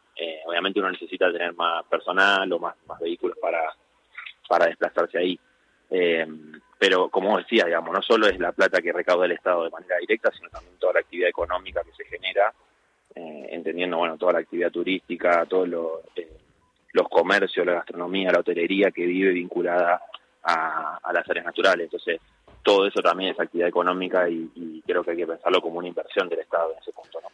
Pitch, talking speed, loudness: 90 Hz, 195 wpm, -24 LUFS